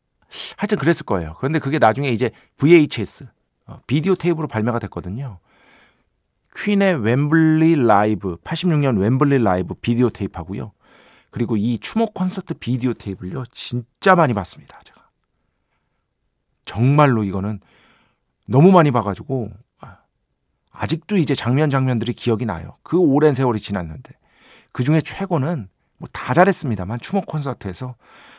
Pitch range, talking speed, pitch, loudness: 110-160 Hz, 315 characters per minute, 125 Hz, -19 LUFS